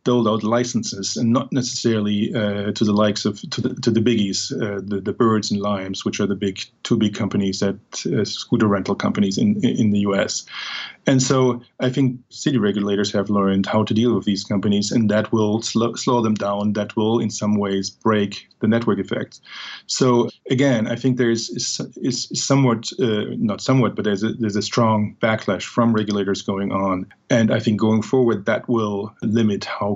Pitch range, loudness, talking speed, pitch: 100-120 Hz, -20 LUFS, 200 wpm, 110 Hz